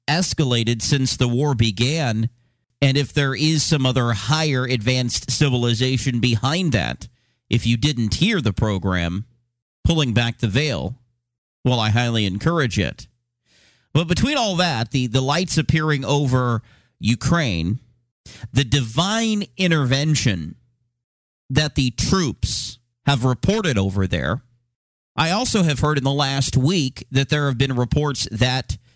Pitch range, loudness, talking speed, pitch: 120-145 Hz, -20 LUFS, 135 wpm, 130 Hz